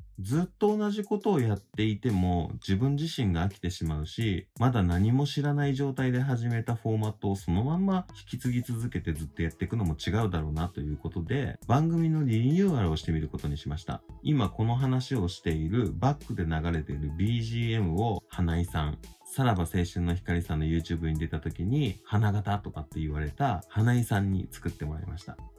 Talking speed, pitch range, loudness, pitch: 410 characters per minute, 85-125 Hz, -29 LUFS, 100 Hz